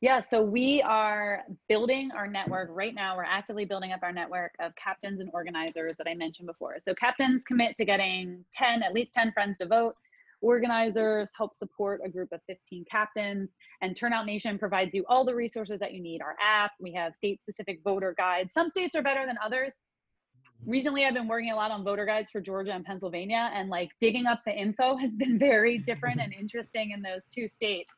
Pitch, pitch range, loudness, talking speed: 210 Hz, 185-235 Hz, -29 LUFS, 210 wpm